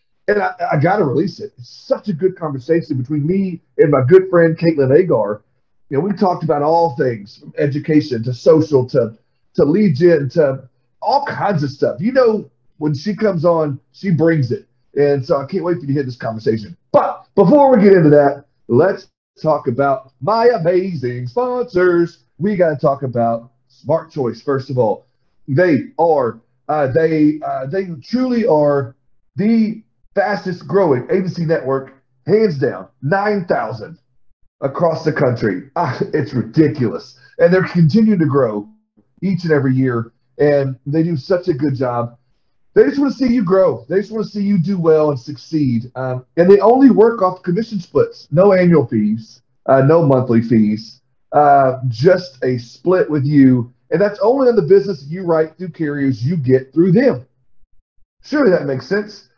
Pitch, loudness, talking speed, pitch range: 155 Hz, -16 LUFS, 175 wpm, 130-185 Hz